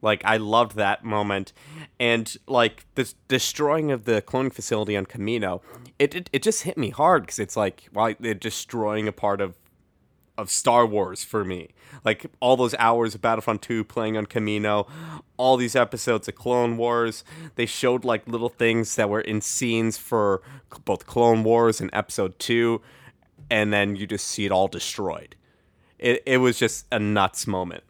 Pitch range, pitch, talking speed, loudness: 105-125 Hz, 115 Hz, 180 wpm, -24 LUFS